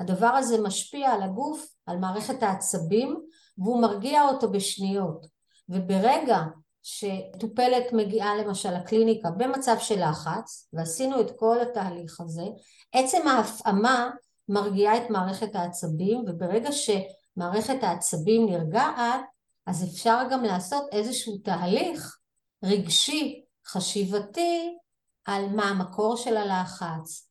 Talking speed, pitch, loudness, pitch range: 105 wpm, 215 Hz, -26 LUFS, 185-240 Hz